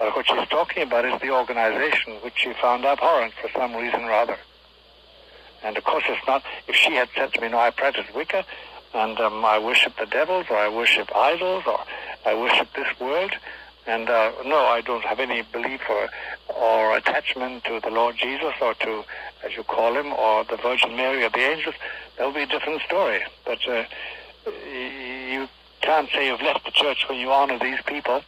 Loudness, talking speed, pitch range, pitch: -22 LUFS, 200 wpm, 115-135 Hz, 125 Hz